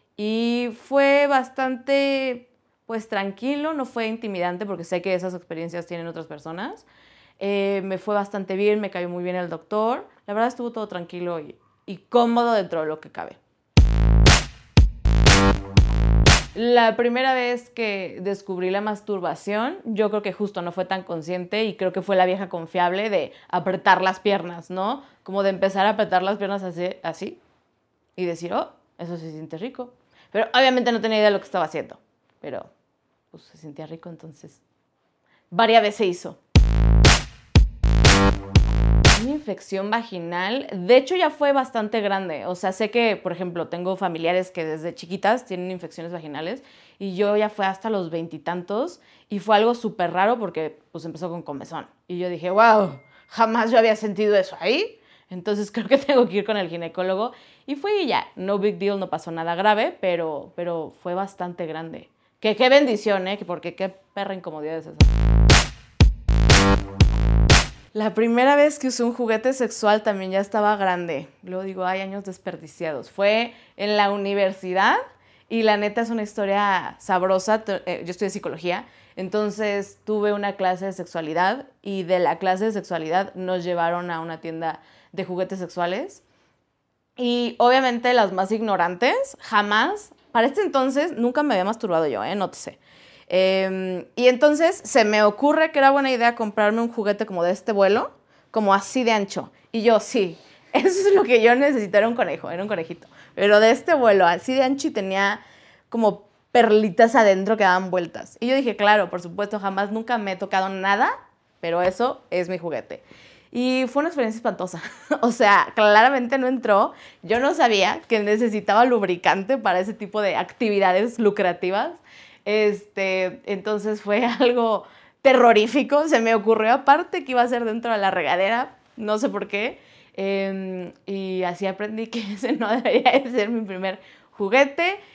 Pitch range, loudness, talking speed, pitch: 180-235 Hz, -21 LUFS, 170 wpm, 205 Hz